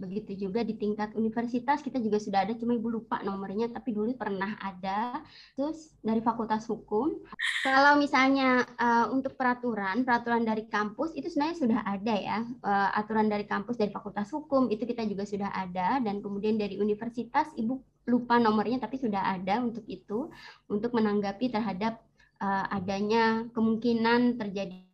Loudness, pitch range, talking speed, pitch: -29 LUFS, 205-245 Hz, 155 wpm, 225 Hz